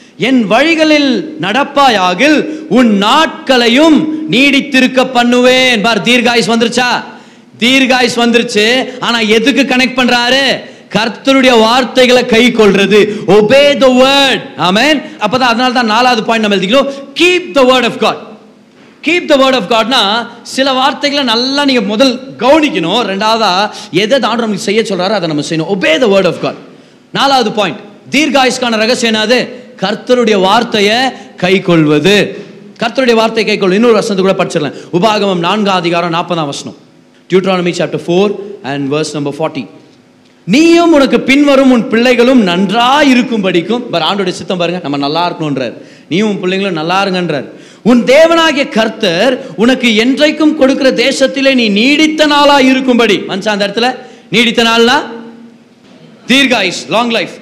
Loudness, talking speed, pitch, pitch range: -9 LUFS, 85 wpm, 235 Hz, 205-265 Hz